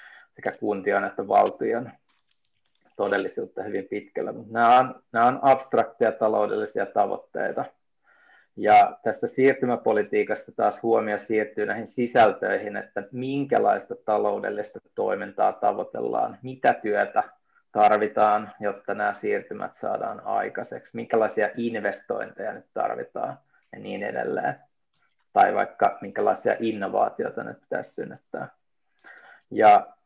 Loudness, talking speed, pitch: -24 LUFS, 105 wpm, 115 Hz